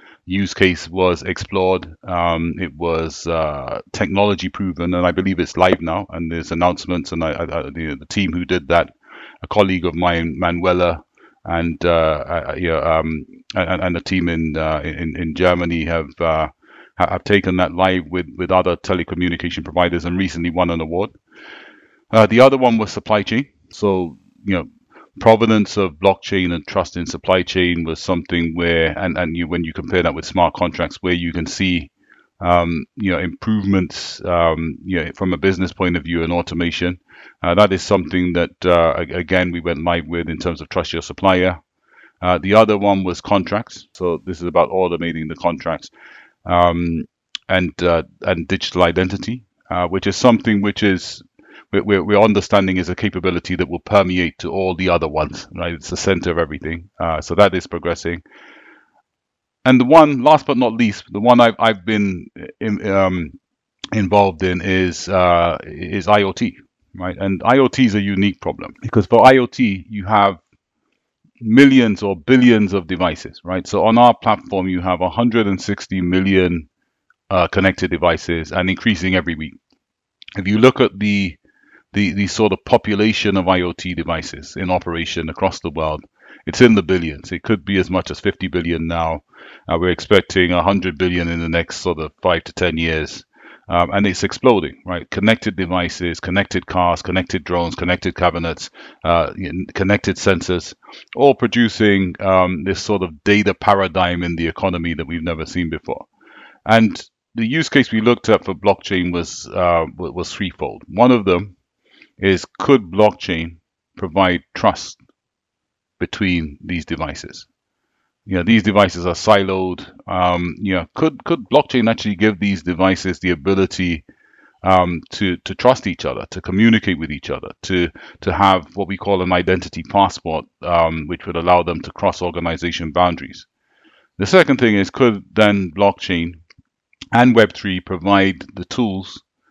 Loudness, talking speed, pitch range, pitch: -17 LUFS, 170 wpm, 85-100 Hz, 90 Hz